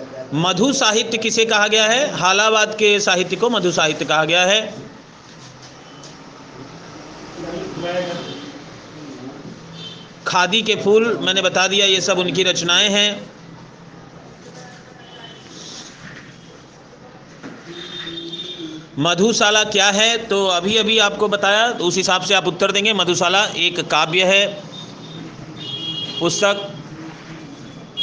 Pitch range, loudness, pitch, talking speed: 165-210 Hz, -16 LUFS, 185 Hz, 100 wpm